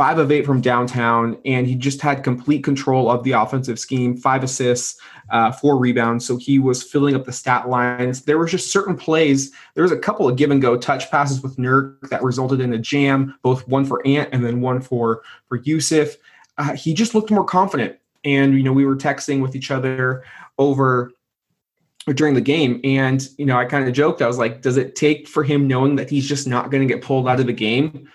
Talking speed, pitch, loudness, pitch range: 230 wpm, 135 Hz, -18 LUFS, 125-145 Hz